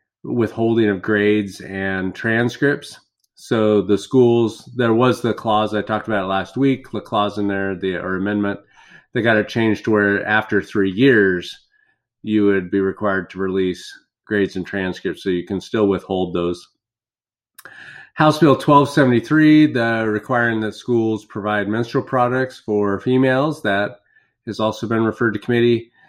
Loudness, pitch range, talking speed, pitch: -18 LUFS, 100-120 Hz, 155 wpm, 110 Hz